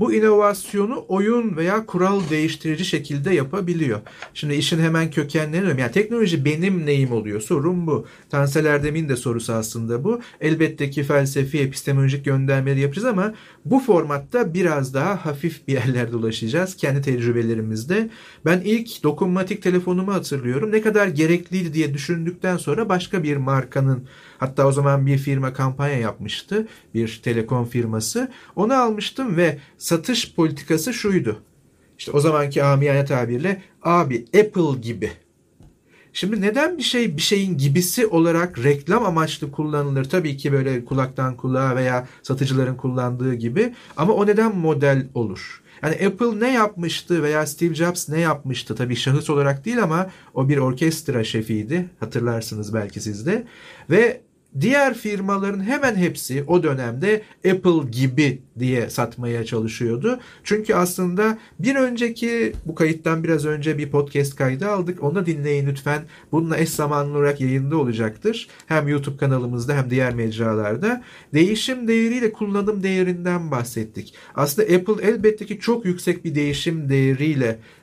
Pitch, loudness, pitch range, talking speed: 155 Hz, -21 LUFS, 135-190 Hz, 140 wpm